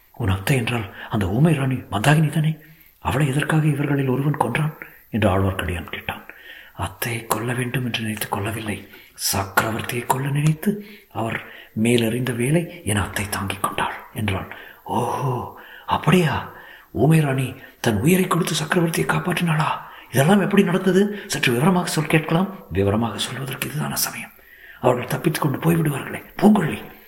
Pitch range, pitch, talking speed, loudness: 115-165 Hz, 140 Hz, 125 wpm, -21 LUFS